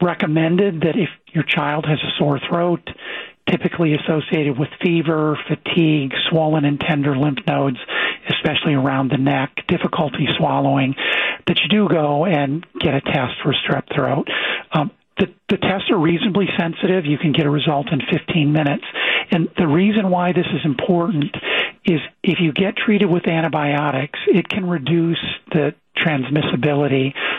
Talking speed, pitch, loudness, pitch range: 155 wpm, 160 Hz, -18 LUFS, 145-180 Hz